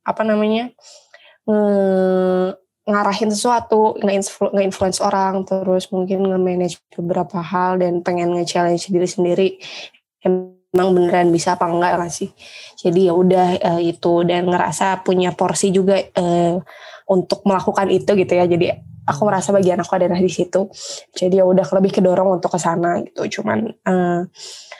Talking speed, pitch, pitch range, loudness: 145 wpm, 185 Hz, 180-195 Hz, -17 LUFS